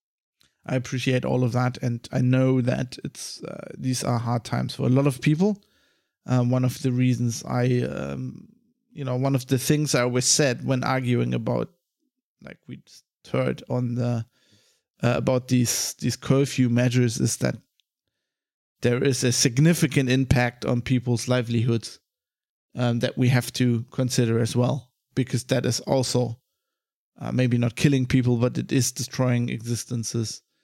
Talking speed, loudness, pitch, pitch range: 165 wpm, -24 LUFS, 125 Hz, 120-135 Hz